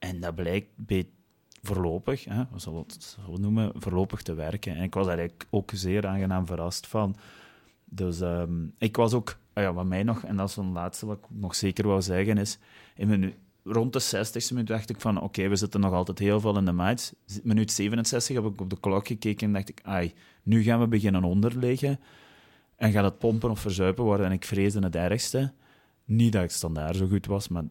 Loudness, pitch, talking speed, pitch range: -28 LUFS, 100 Hz, 220 wpm, 95-110 Hz